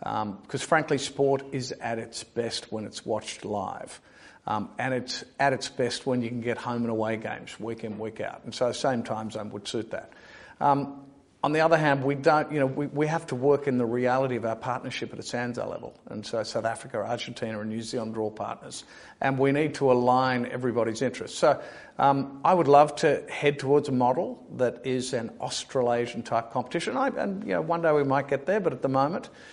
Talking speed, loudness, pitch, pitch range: 220 wpm, -27 LUFS, 125 Hz, 115-140 Hz